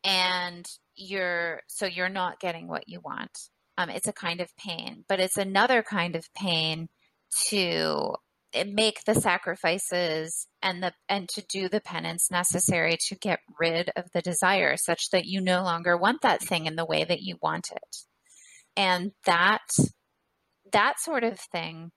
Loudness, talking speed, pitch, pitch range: -27 LUFS, 165 wpm, 180 Hz, 170-200 Hz